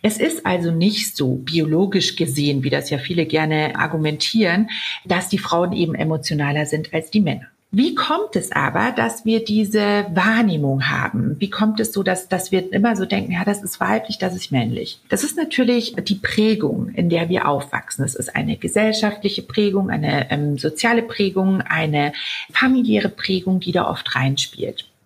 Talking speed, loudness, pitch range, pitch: 175 wpm, -19 LUFS, 155-215 Hz, 185 Hz